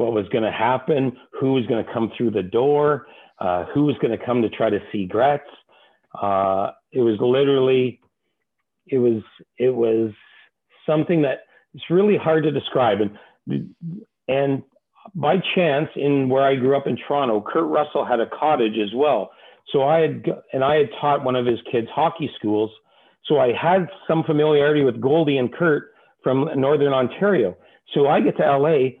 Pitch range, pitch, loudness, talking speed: 120-150 Hz, 135 Hz, -20 LUFS, 180 wpm